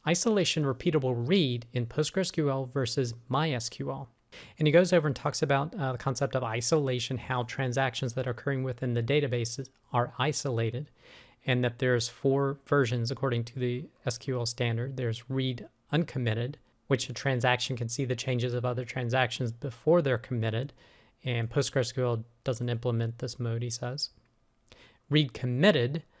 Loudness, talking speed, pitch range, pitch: -30 LUFS, 150 wpm, 120-140 Hz, 130 Hz